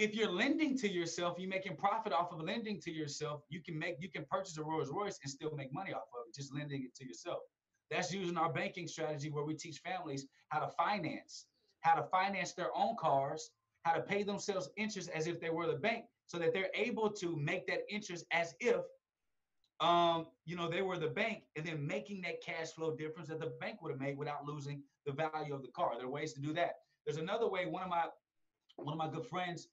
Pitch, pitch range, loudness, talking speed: 165 Hz, 150-185 Hz, -39 LUFS, 235 wpm